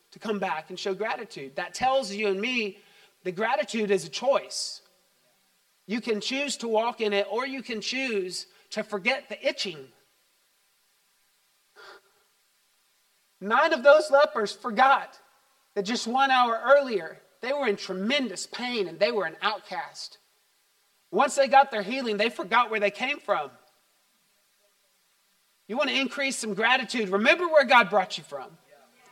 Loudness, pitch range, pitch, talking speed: -25 LUFS, 200-245 Hz, 200 Hz, 150 wpm